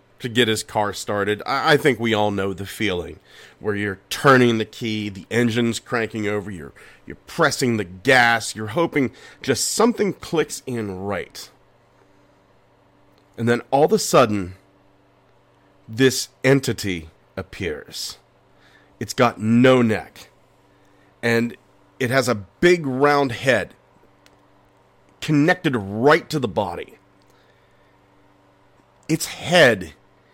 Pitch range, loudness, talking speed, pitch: 95-130 Hz, -20 LUFS, 120 wpm, 110 Hz